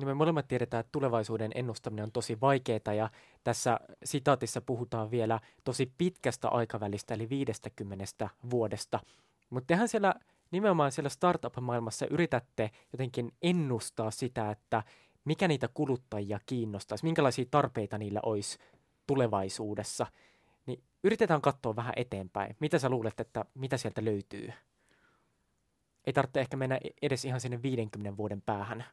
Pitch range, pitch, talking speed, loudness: 110-140 Hz, 120 Hz, 130 wpm, -33 LUFS